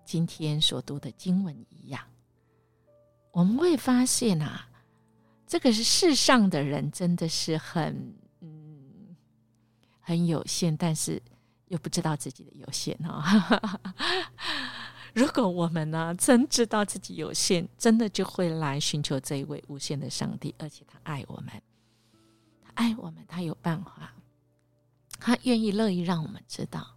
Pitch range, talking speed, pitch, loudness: 135-200 Hz, 210 characters per minute, 160 Hz, -27 LUFS